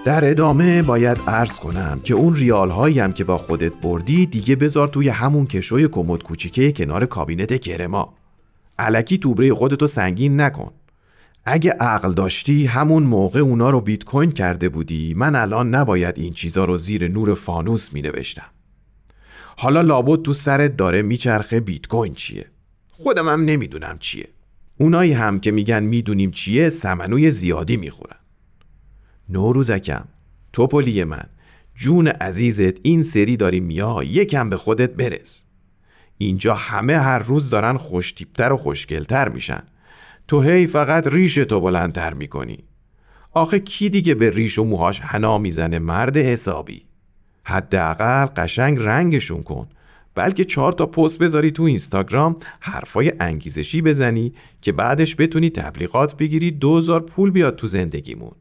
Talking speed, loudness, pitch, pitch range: 140 wpm, -18 LUFS, 120 Hz, 95-150 Hz